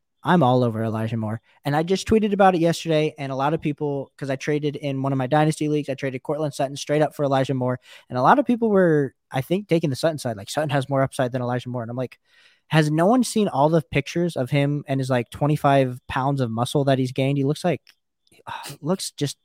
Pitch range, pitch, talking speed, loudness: 130-155 Hz, 140 Hz, 255 wpm, -22 LUFS